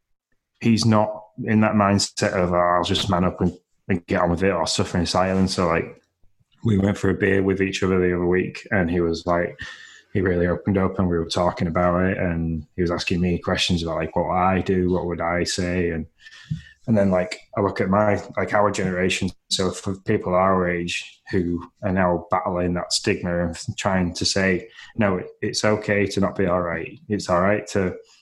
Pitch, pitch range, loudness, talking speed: 90 Hz, 90-100 Hz, -22 LUFS, 210 wpm